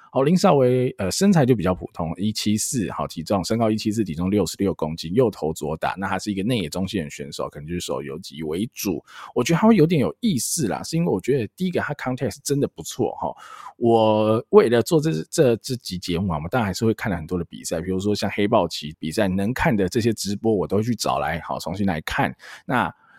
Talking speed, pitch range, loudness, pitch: 360 characters per minute, 90-125 Hz, -22 LUFS, 105 Hz